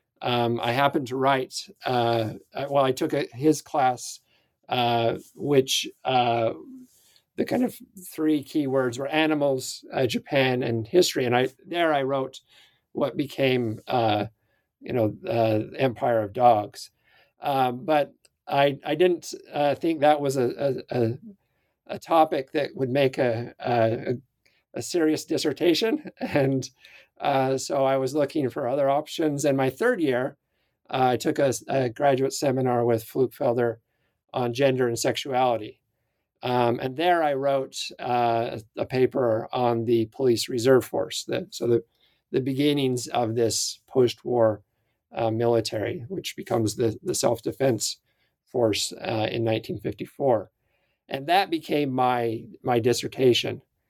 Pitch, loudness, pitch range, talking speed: 130 Hz, -25 LUFS, 120-140 Hz, 140 wpm